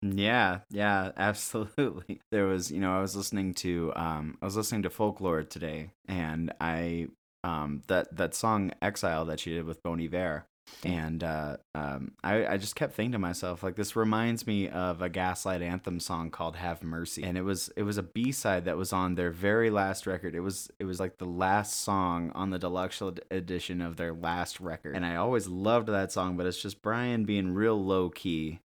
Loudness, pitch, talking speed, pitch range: -31 LUFS, 90 Hz, 205 wpm, 85-100 Hz